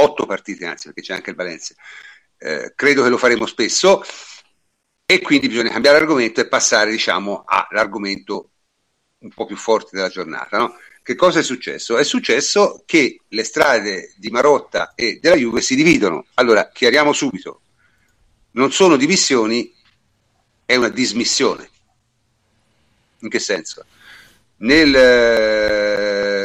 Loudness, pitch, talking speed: -16 LUFS, 125 Hz, 135 wpm